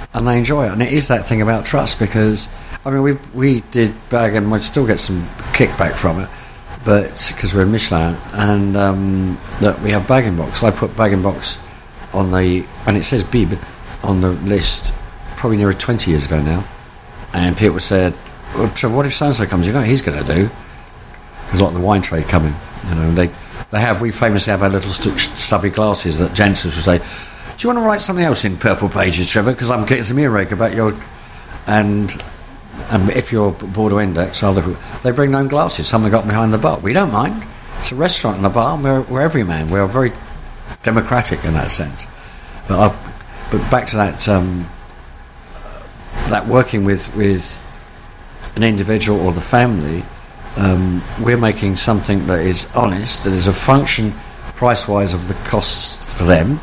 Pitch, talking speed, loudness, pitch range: 105 Hz, 195 wpm, -15 LUFS, 90-115 Hz